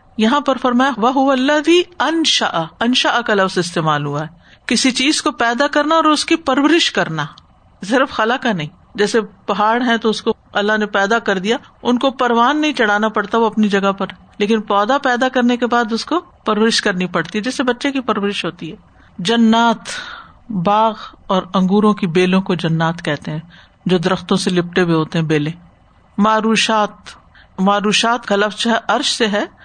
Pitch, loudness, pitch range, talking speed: 220 Hz, -16 LUFS, 195-250 Hz, 185 wpm